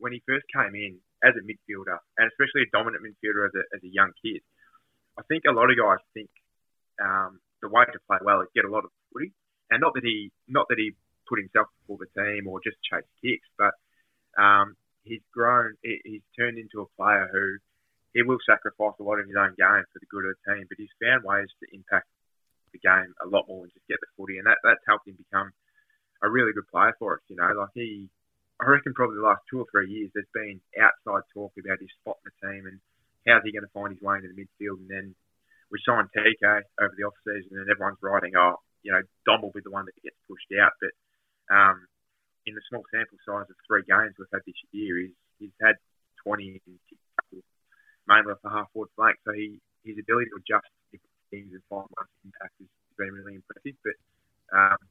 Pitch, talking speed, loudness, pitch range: 100 Hz, 230 wpm, -24 LUFS, 95-110 Hz